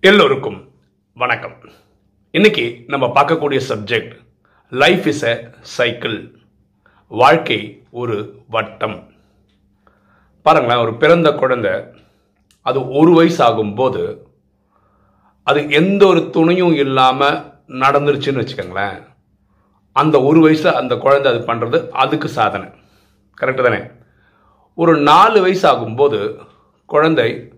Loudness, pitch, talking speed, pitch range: -14 LUFS, 150 Hz, 95 wpm, 135-175 Hz